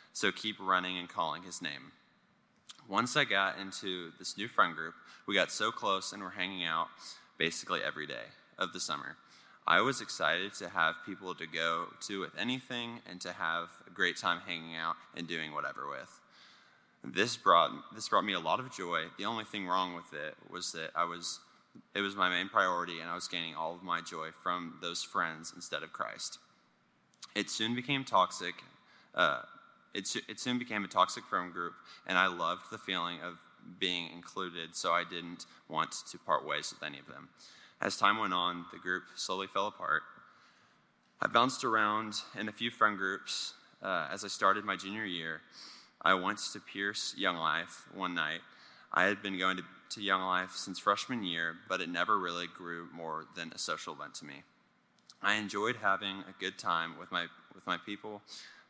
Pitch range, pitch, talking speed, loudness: 85-100 Hz, 90 Hz, 190 wpm, -34 LUFS